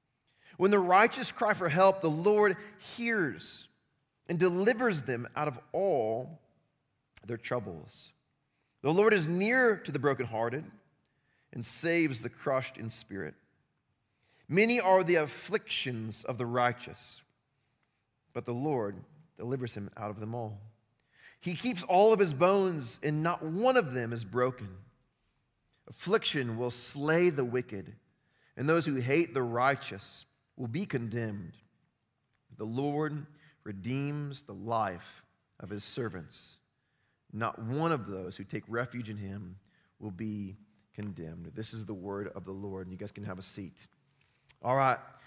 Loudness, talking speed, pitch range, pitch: -31 LUFS, 145 wpm, 110-160 Hz, 130 Hz